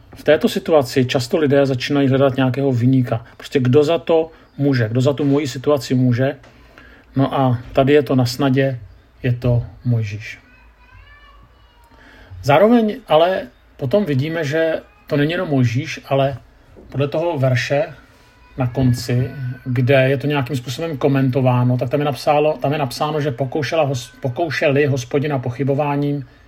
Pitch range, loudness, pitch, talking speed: 130-150 Hz, -18 LUFS, 140 Hz, 145 wpm